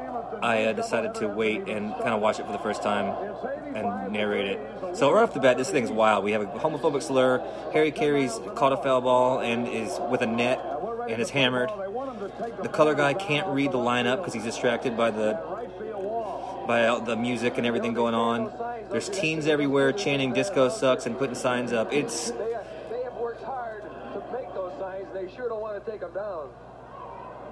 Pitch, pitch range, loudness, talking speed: 135 Hz, 120-185 Hz, -26 LUFS, 195 wpm